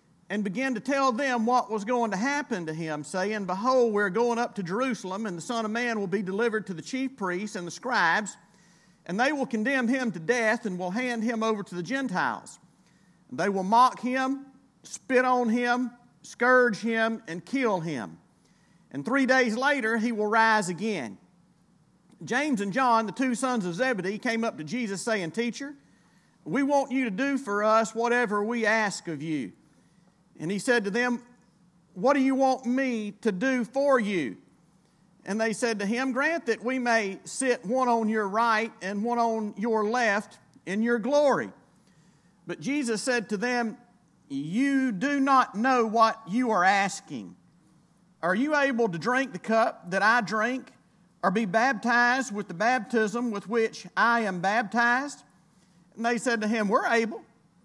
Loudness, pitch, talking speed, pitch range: -26 LUFS, 225 Hz, 180 wpm, 195-250 Hz